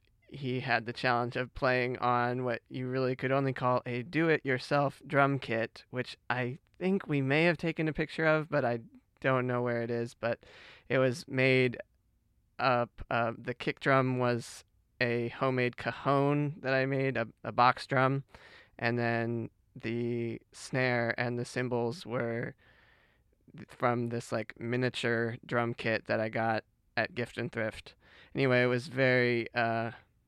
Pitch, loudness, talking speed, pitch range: 125 Hz, -31 LUFS, 160 wpm, 120-135 Hz